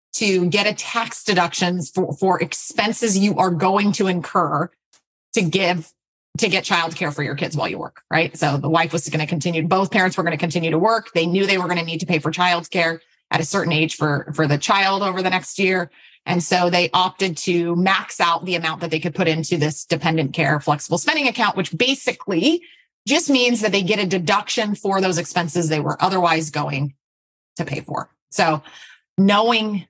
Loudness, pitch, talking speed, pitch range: -19 LUFS, 175 Hz, 215 wpm, 160-195 Hz